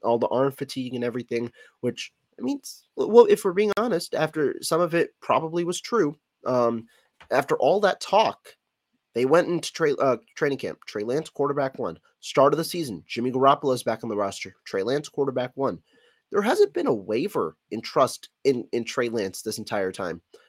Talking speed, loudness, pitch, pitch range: 195 wpm, -25 LUFS, 135 Hz, 120-175 Hz